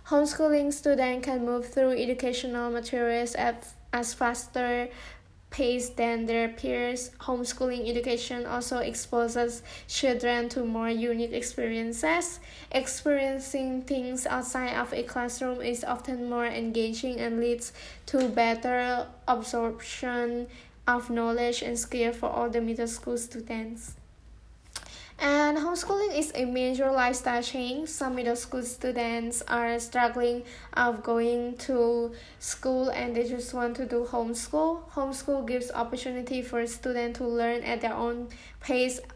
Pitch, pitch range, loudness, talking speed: 245 Hz, 235-255 Hz, -29 LUFS, 125 wpm